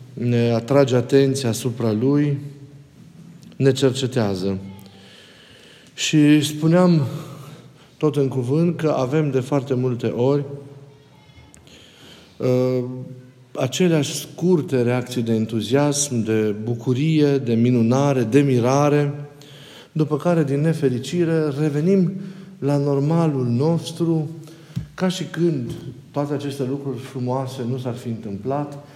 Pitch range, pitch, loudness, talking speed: 125-150 Hz, 140 Hz, -20 LUFS, 100 wpm